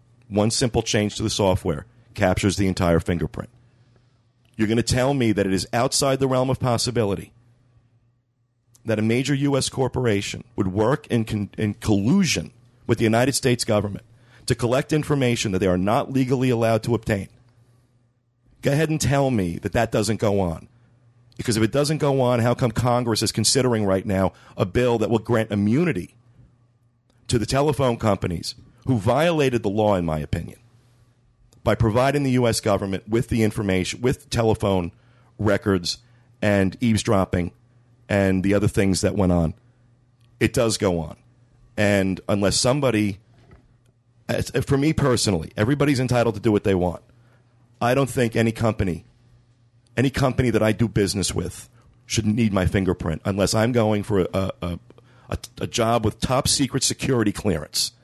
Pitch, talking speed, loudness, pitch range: 115 Hz, 165 wpm, -22 LUFS, 105-120 Hz